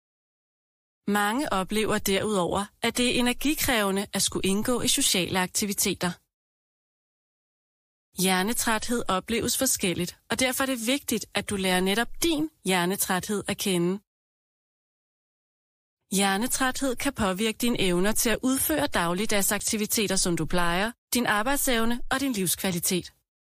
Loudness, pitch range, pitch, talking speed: -25 LUFS, 190-245 Hz, 210 Hz, 115 wpm